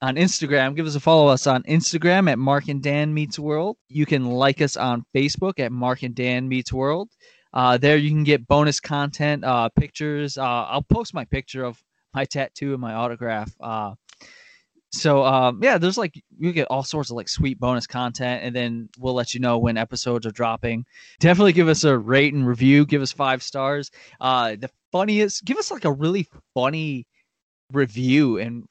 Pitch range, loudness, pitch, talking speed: 125-150 Hz, -21 LUFS, 135 Hz, 195 wpm